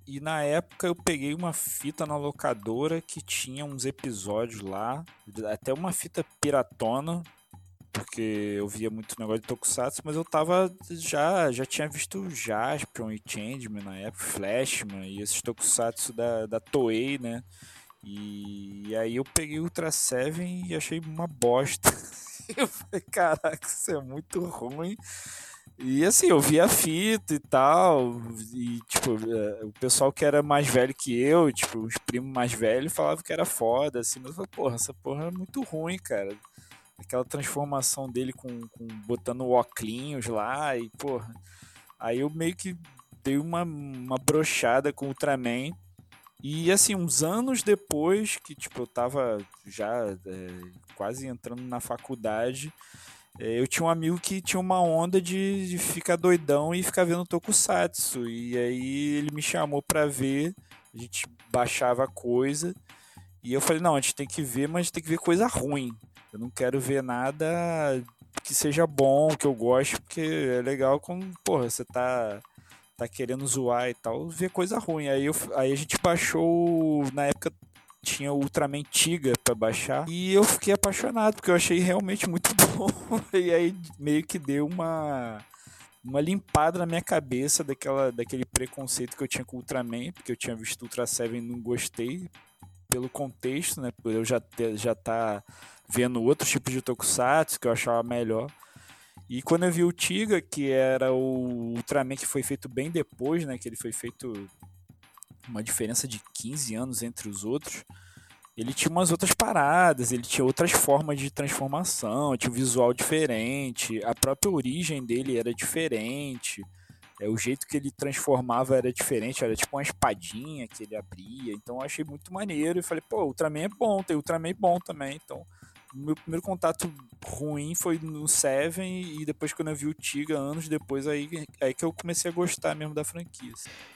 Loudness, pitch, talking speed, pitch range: -27 LUFS, 135 Hz, 175 wpm, 120-160 Hz